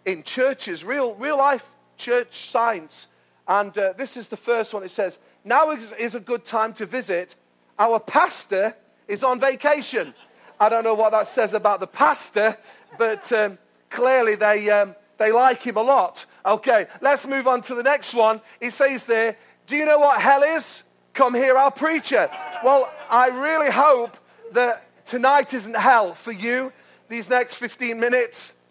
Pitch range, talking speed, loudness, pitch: 220-270 Hz, 175 wpm, -21 LUFS, 245 Hz